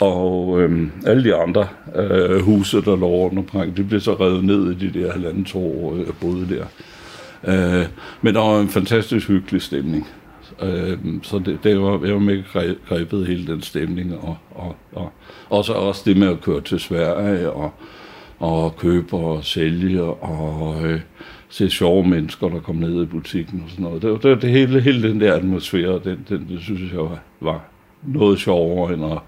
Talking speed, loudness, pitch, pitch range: 195 wpm, -19 LUFS, 90 Hz, 85-100 Hz